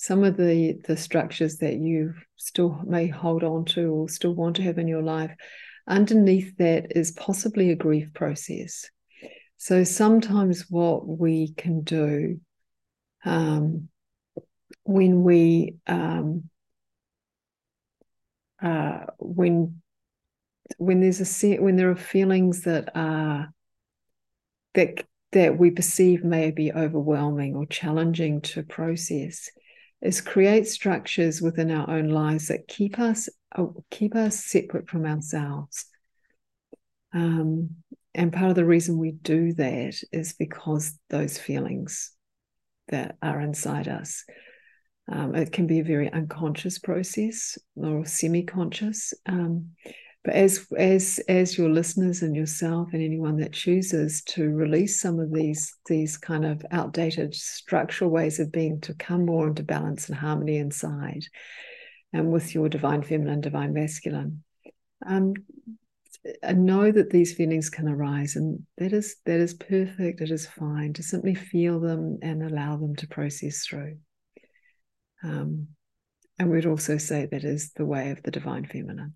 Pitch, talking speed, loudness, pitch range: 165 Hz, 140 wpm, -25 LUFS, 155-185 Hz